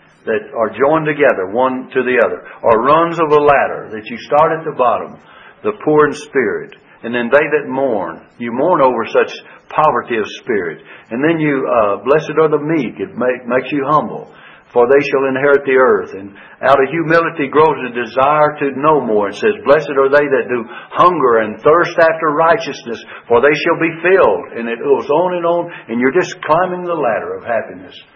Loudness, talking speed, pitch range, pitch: -14 LUFS, 200 wpm, 130-170 Hz, 150 Hz